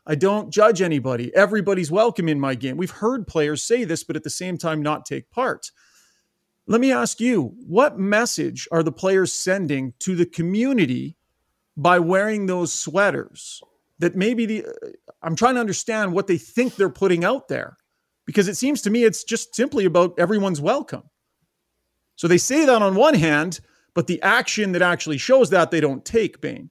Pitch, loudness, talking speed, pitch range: 190 Hz, -20 LUFS, 185 wpm, 165-220 Hz